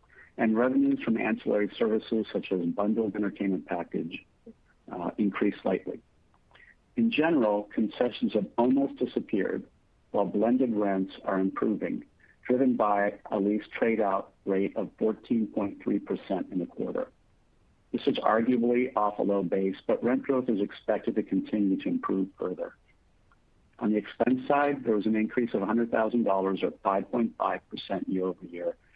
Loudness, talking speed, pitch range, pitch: -29 LUFS, 140 wpm, 95-125 Hz, 105 Hz